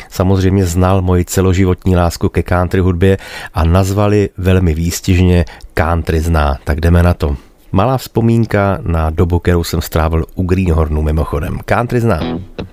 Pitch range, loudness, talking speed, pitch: 85-95 Hz, -14 LUFS, 140 wpm, 90 Hz